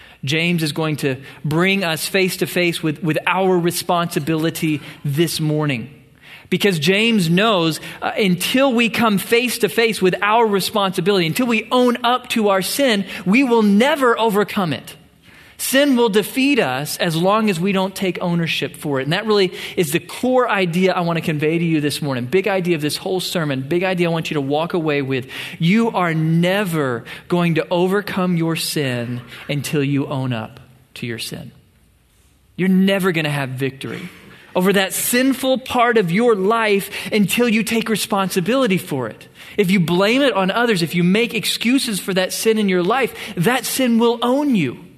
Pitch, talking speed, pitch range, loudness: 185 Hz, 185 wpm, 160-215 Hz, -18 LUFS